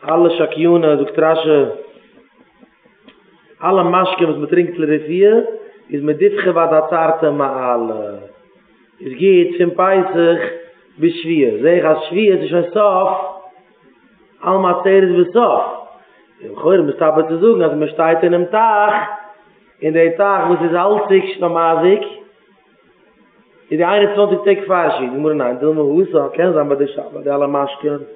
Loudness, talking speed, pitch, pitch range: -14 LUFS, 135 wpm, 175 Hz, 155-205 Hz